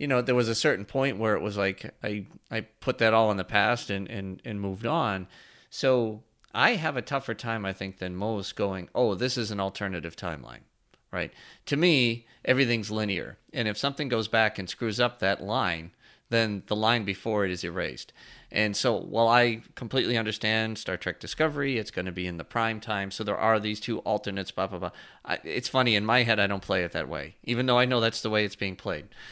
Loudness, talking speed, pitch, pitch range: -28 LUFS, 225 wpm, 110 Hz, 95-120 Hz